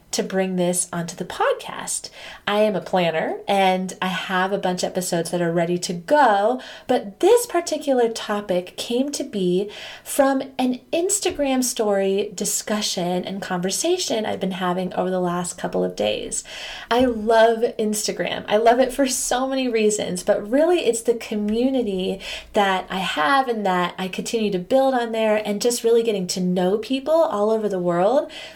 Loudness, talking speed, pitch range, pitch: -21 LUFS, 170 wpm, 185-250 Hz, 210 Hz